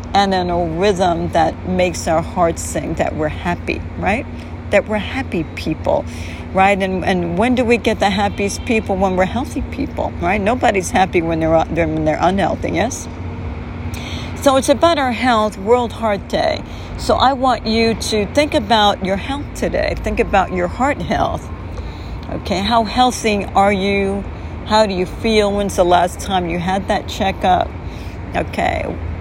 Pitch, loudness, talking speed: 190 Hz, -17 LUFS, 165 wpm